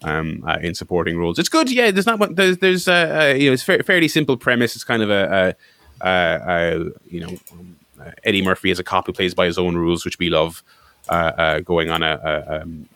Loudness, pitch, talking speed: -18 LUFS, 90 Hz, 250 wpm